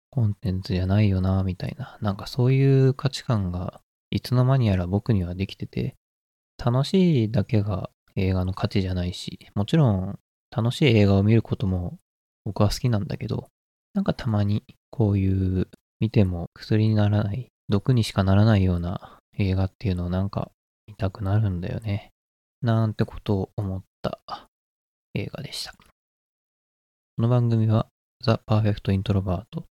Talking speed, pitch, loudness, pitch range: 330 characters per minute, 105 Hz, -24 LUFS, 95-115 Hz